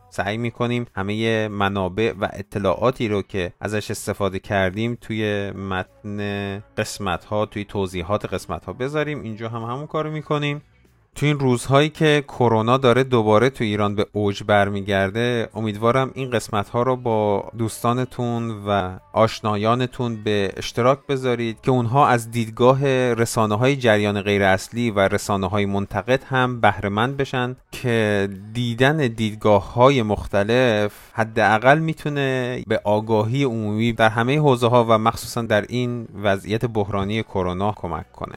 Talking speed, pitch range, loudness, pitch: 140 wpm, 100-125 Hz, -21 LUFS, 110 Hz